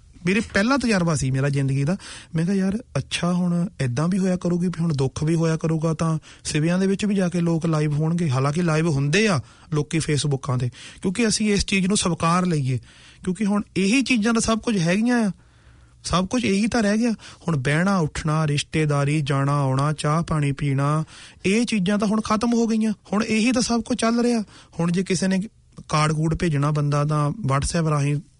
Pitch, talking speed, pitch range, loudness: 170 Hz, 200 wpm, 150-205 Hz, -22 LUFS